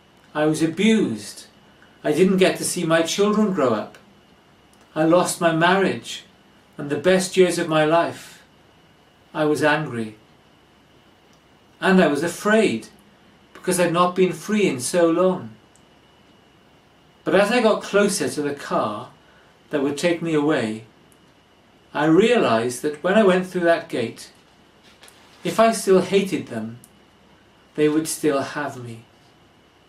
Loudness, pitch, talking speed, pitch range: -20 LUFS, 165 Hz, 140 wpm, 150-185 Hz